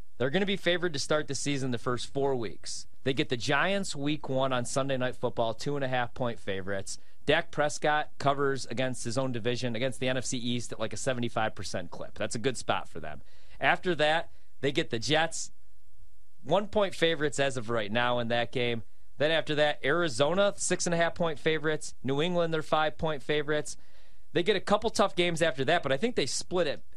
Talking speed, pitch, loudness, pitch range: 215 wpm, 135 Hz, -30 LUFS, 120-155 Hz